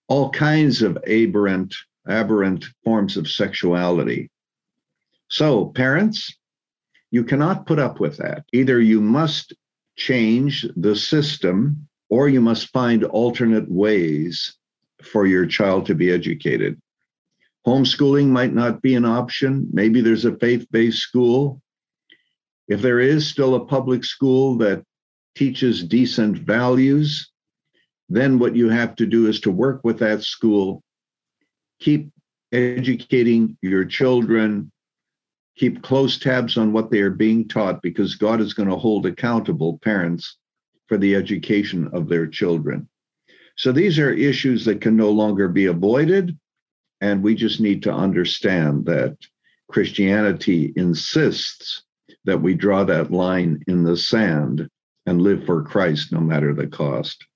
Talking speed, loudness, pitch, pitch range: 135 wpm, -19 LUFS, 115 Hz, 100-130 Hz